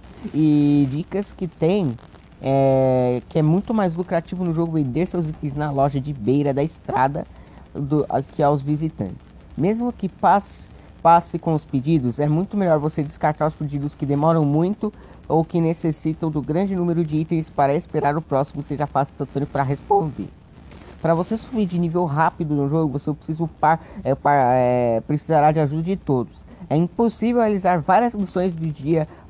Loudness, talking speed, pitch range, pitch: -21 LUFS, 170 wpm, 145-170 Hz, 155 Hz